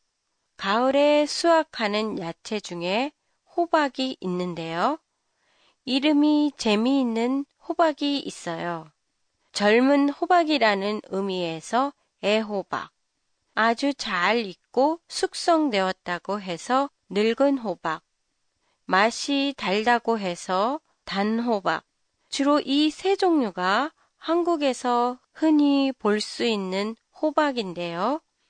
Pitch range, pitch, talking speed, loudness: 195-290 Hz, 240 Hz, 200 characters per minute, -24 LUFS